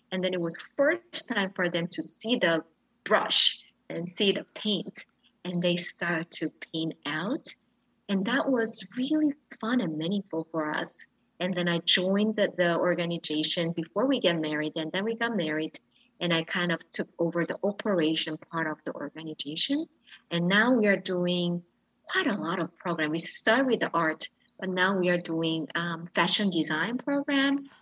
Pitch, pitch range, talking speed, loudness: 175 Hz, 165-220 Hz, 180 wpm, -28 LUFS